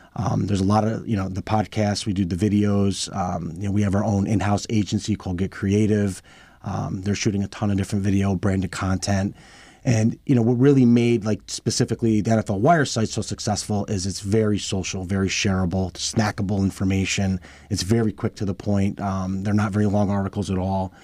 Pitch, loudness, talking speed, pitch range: 100 Hz, -22 LUFS, 205 wpm, 95-110 Hz